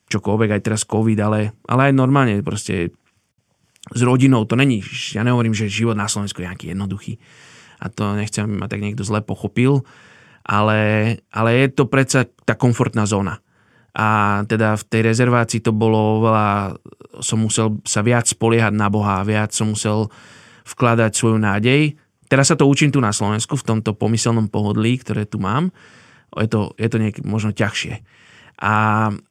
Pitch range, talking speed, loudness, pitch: 105-120 Hz, 170 wpm, -18 LUFS, 110 Hz